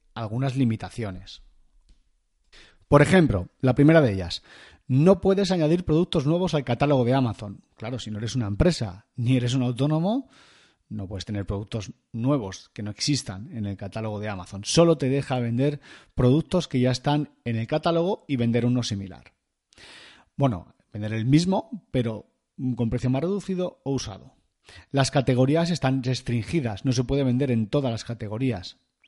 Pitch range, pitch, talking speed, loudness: 110-145 Hz, 130 Hz, 160 wpm, -24 LUFS